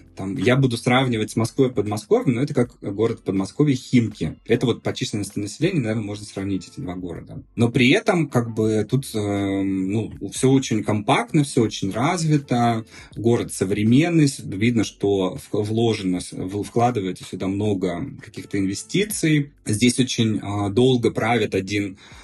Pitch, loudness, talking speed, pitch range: 110 Hz, -22 LUFS, 145 wpm, 100-130 Hz